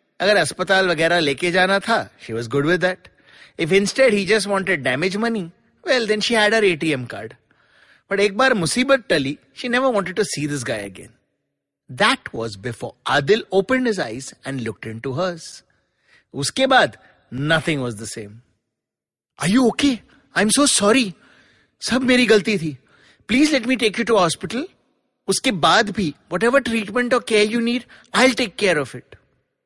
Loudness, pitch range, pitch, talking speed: -19 LUFS, 145-235 Hz, 195 Hz, 175 wpm